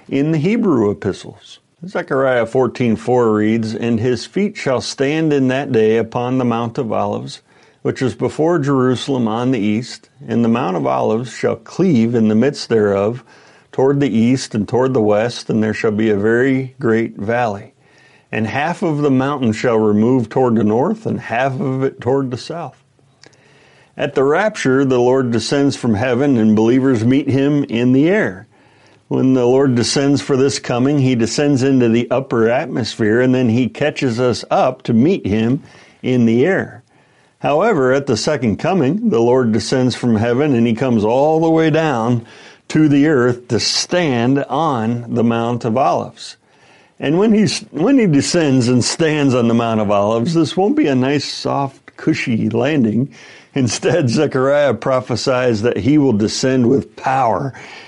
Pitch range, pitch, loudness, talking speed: 115-140 Hz, 130 Hz, -16 LUFS, 175 wpm